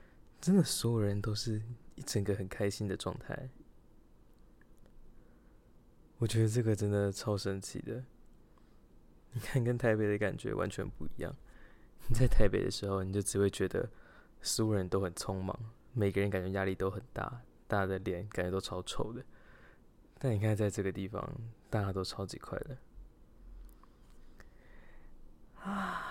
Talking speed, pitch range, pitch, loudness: 220 characters per minute, 95-115 Hz, 105 Hz, -35 LUFS